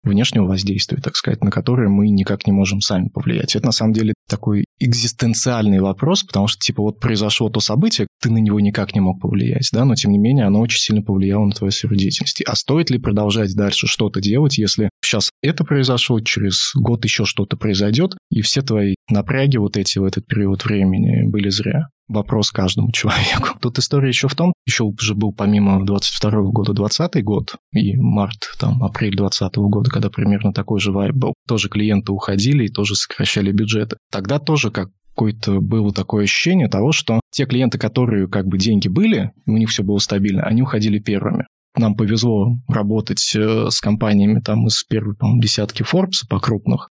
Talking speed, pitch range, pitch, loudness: 185 wpm, 100-120 Hz, 105 Hz, -17 LUFS